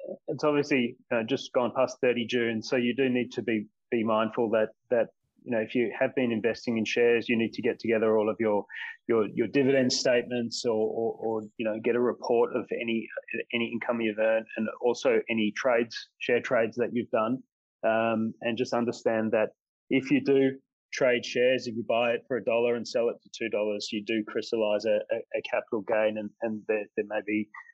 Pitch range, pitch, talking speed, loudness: 110-125 Hz, 115 Hz, 210 wpm, -28 LUFS